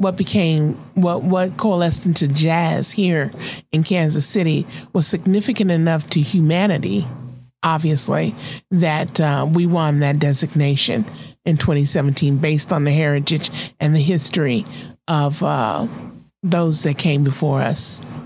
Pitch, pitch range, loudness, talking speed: 160 Hz, 145-175 Hz, -17 LUFS, 130 wpm